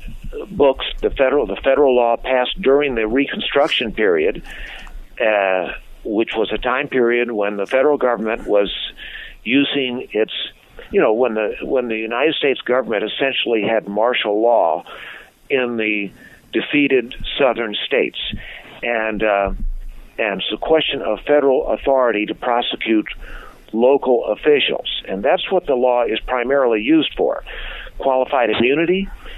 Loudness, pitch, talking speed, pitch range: -18 LUFS, 125 Hz, 135 wpm, 110-145 Hz